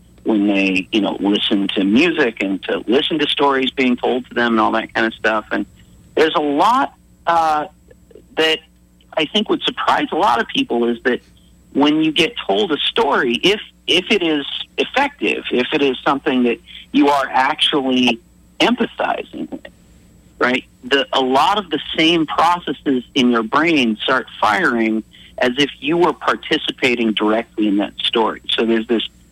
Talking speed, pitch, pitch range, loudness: 170 wpm, 125 Hz, 105-150 Hz, -17 LUFS